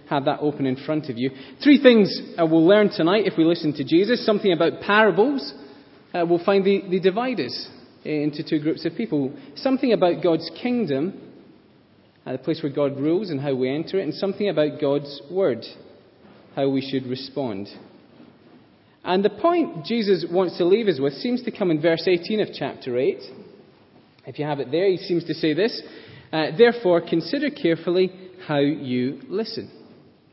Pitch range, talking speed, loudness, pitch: 145-200 Hz, 180 wpm, -22 LUFS, 170 Hz